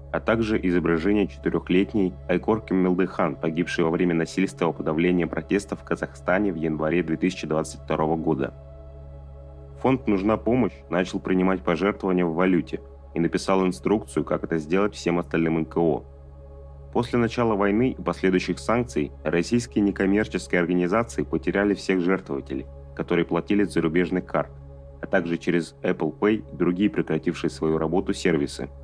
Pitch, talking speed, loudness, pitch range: 85 Hz, 130 wpm, -24 LUFS, 80-95 Hz